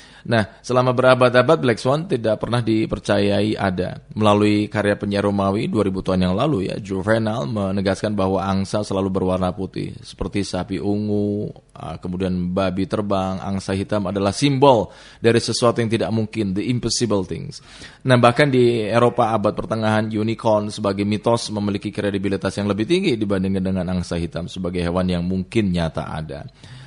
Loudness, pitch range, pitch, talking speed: -20 LUFS, 95-115 Hz, 105 Hz, 145 wpm